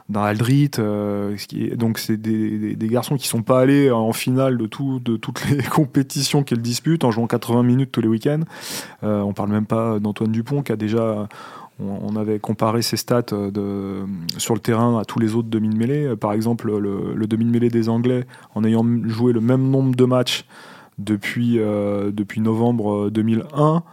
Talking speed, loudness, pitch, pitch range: 195 wpm, -20 LUFS, 115 Hz, 105-125 Hz